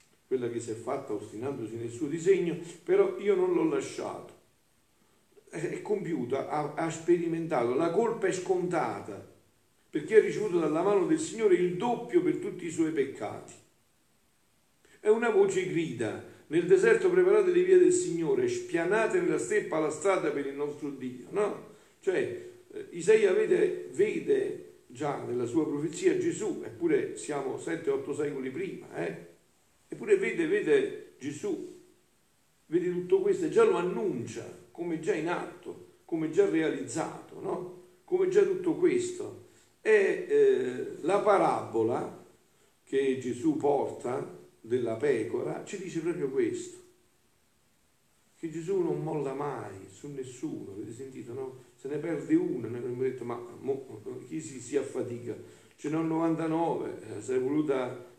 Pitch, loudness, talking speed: 365 Hz, -29 LUFS, 140 wpm